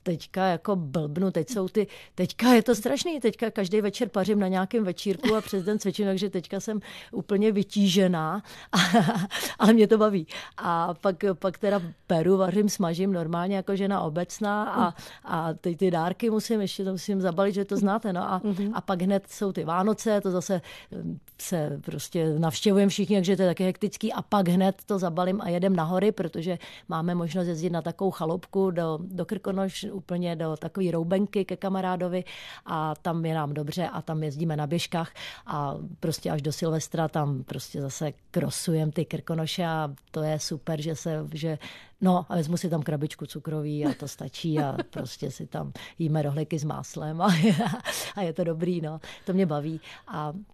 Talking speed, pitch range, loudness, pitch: 180 wpm, 165-200 Hz, -27 LUFS, 180 Hz